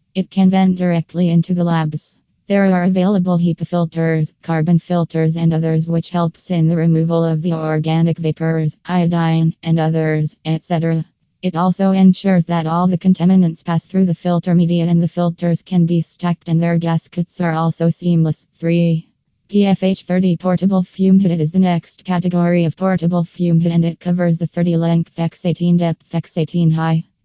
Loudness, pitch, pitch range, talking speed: -16 LUFS, 170 Hz, 165-180 Hz, 175 wpm